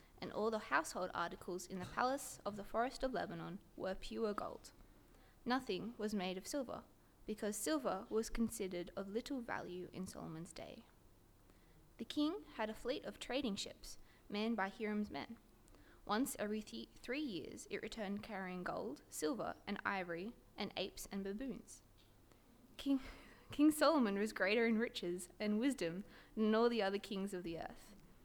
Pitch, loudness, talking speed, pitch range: 210 Hz, -42 LUFS, 160 wpm, 190-235 Hz